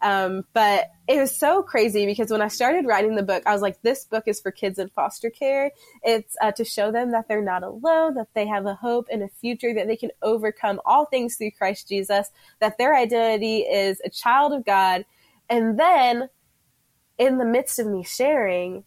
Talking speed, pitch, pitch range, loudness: 210 wpm, 220 Hz, 200-245 Hz, -22 LUFS